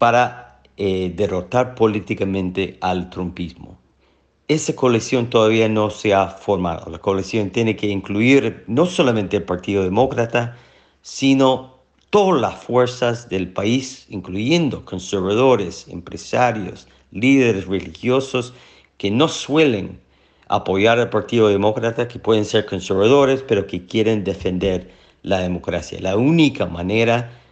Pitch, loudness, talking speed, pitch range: 110 Hz, -19 LUFS, 120 wpm, 95-125 Hz